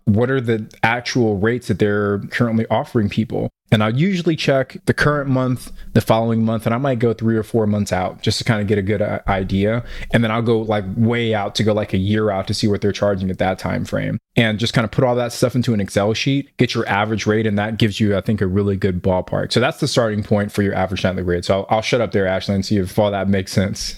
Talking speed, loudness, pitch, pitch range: 275 wpm, -19 LUFS, 110 Hz, 100-115 Hz